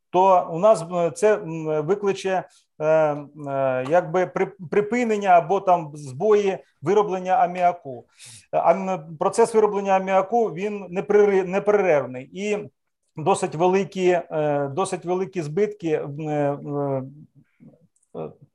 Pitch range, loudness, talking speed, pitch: 155-195 Hz, -22 LUFS, 80 wpm, 185 Hz